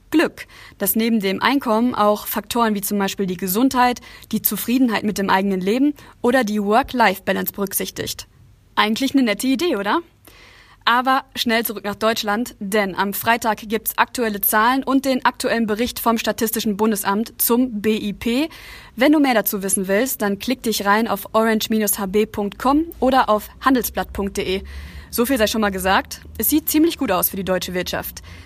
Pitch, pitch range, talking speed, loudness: 215 Hz, 200-245 Hz, 165 wpm, -19 LUFS